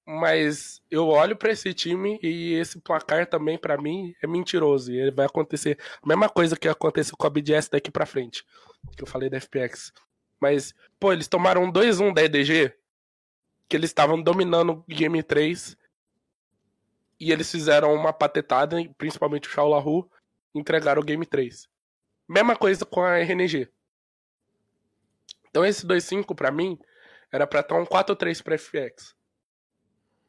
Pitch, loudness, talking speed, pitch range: 160 Hz, -23 LUFS, 155 wpm, 150-180 Hz